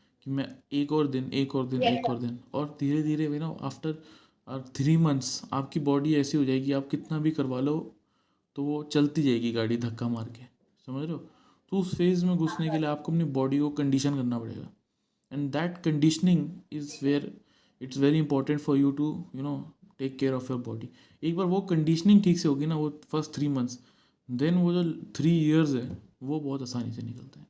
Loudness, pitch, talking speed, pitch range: -28 LUFS, 145 Hz, 205 wpm, 130-155 Hz